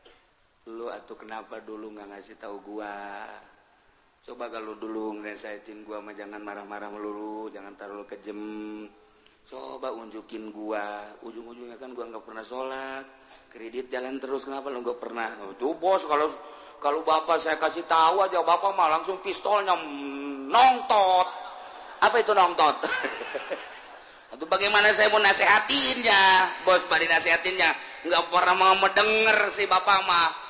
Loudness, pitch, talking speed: -23 LUFS, 140 Hz, 140 wpm